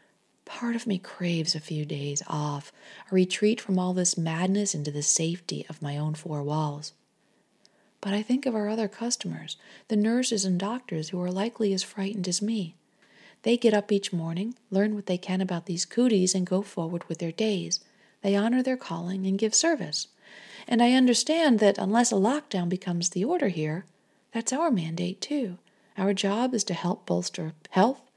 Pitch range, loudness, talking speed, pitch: 170-220 Hz, -27 LUFS, 185 wpm, 195 Hz